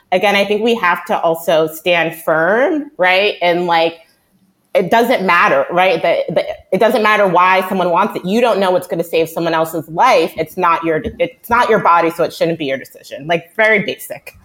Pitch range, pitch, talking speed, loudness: 165-205 Hz, 180 Hz, 210 wpm, -14 LUFS